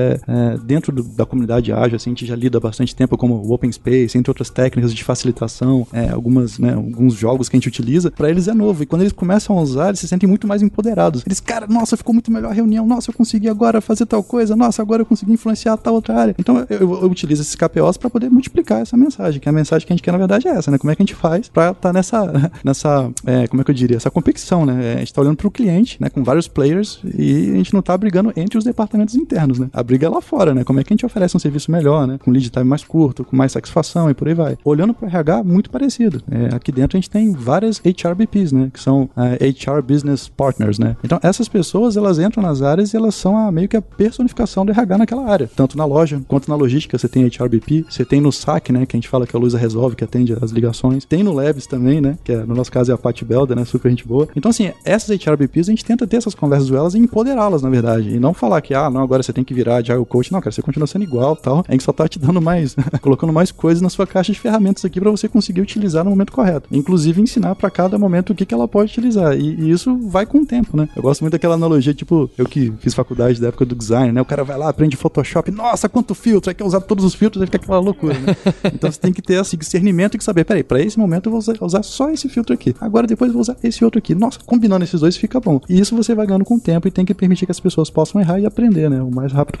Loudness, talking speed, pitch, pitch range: -16 LUFS, 280 wpm, 165 Hz, 130-210 Hz